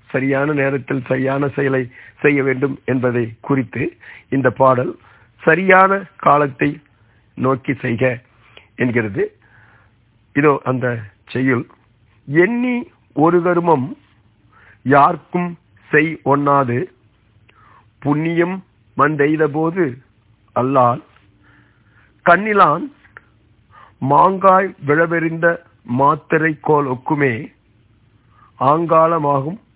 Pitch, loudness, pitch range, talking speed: 135 Hz, -17 LUFS, 115-155 Hz, 65 wpm